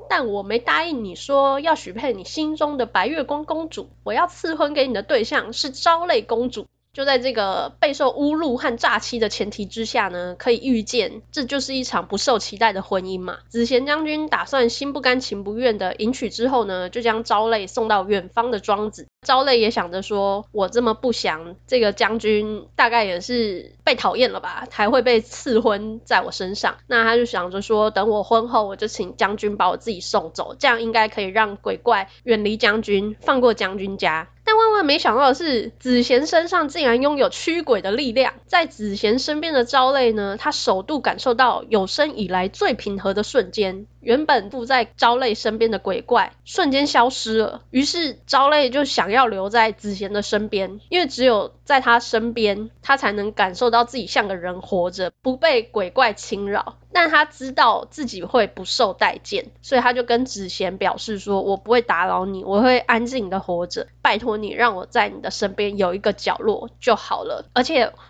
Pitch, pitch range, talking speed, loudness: 230 Hz, 205-265 Hz, 285 characters per minute, -20 LUFS